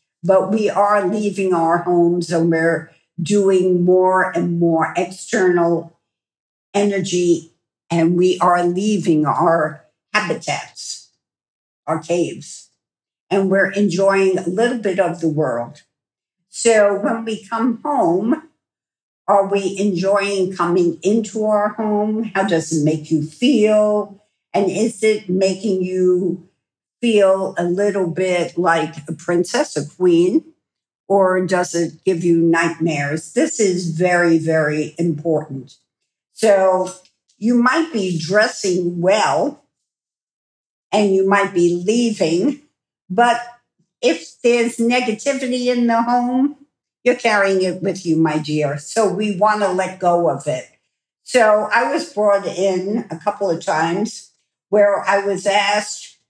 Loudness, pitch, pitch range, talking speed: -17 LUFS, 190 Hz, 170-210 Hz, 130 wpm